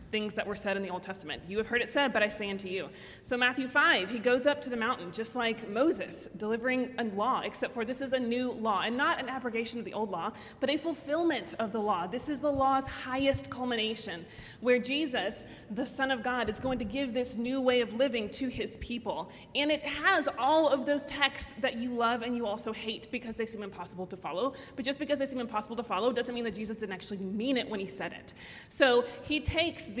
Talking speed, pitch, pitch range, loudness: 245 wpm, 245 Hz, 215-270 Hz, -31 LUFS